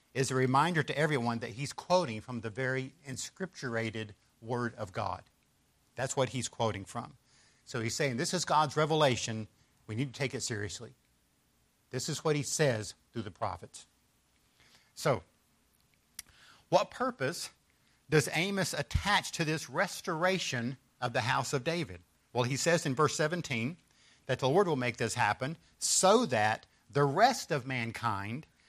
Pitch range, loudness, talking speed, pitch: 115-150 Hz, -32 LUFS, 155 wpm, 130 Hz